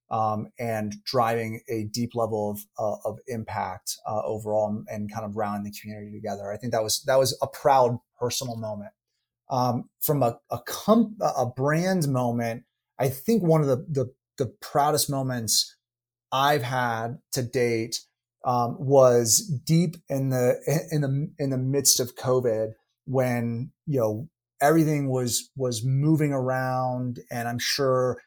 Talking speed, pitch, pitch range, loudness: 155 wpm, 125 Hz, 115-135 Hz, -25 LUFS